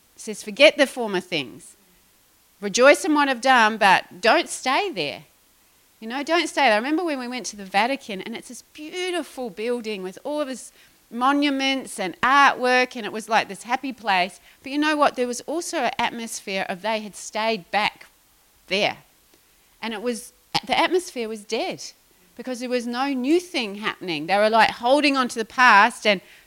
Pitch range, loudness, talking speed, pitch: 215-275 Hz, -21 LUFS, 195 wpm, 245 Hz